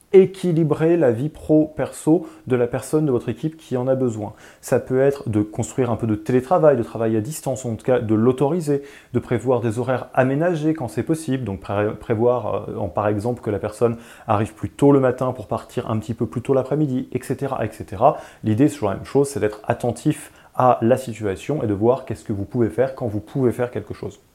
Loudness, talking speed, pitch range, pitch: -21 LUFS, 220 wpm, 110-140 Hz, 125 Hz